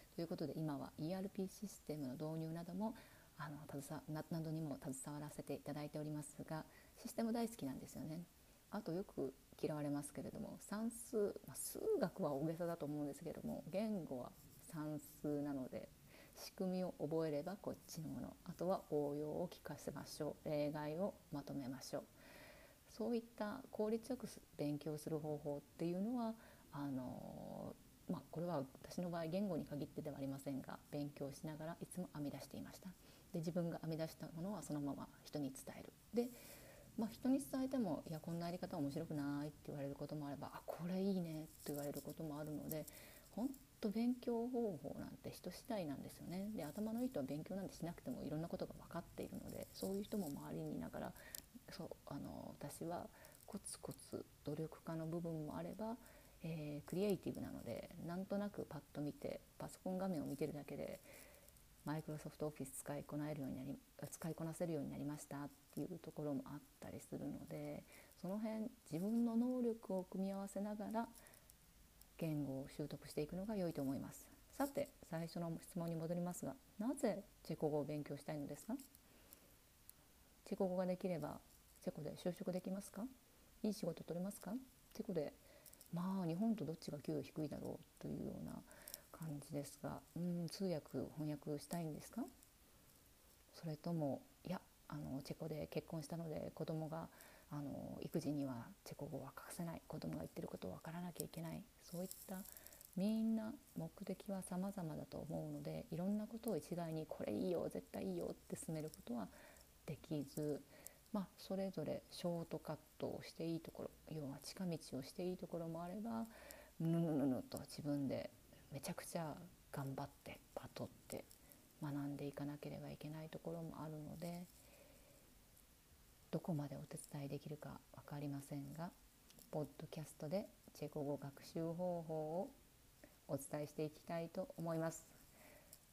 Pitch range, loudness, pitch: 145-195 Hz, -47 LUFS, 160 Hz